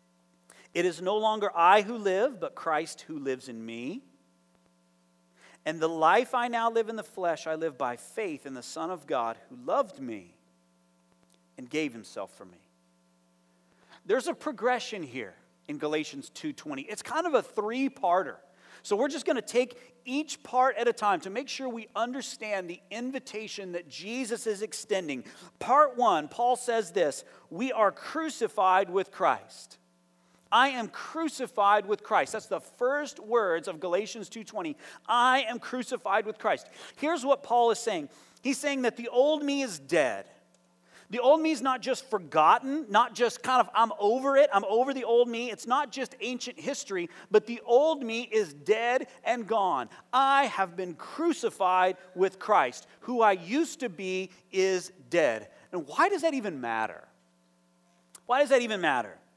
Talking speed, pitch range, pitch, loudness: 170 wpm, 165-255 Hz, 220 Hz, -28 LUFS